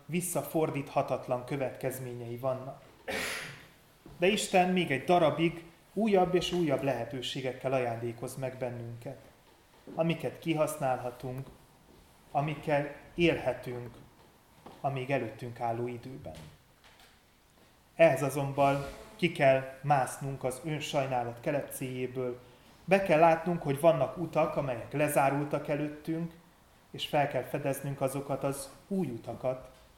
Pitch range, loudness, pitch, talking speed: 130-155 Hz, -31 LUFS, 140 Hz, 100 wpm